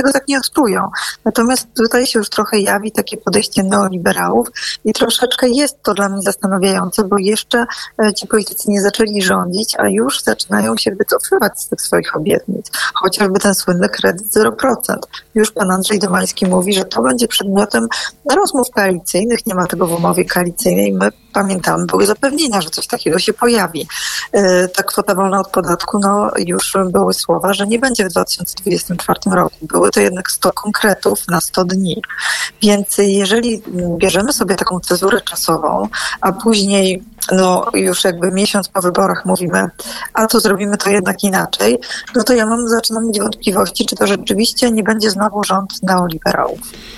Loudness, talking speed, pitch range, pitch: -14 LUFS, 160 wpm, 190-225 Hz, 205 Hz